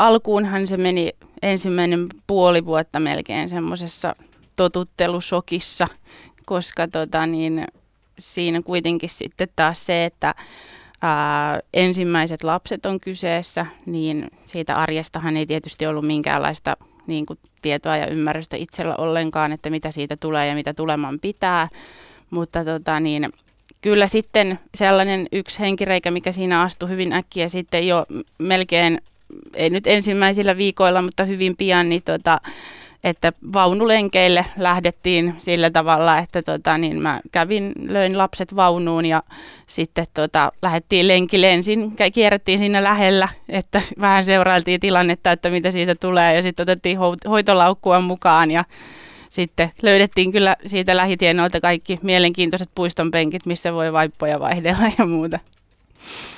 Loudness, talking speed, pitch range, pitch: -19 LUFS, 125 wpm, 165-190 Hz, 175 Hz